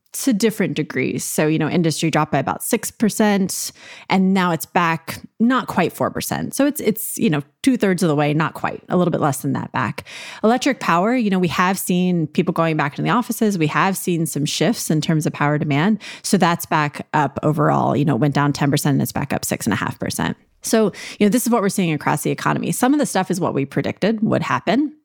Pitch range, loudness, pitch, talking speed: 155-220 Hz, -19 LUFS, 180 Hz, 245 wpm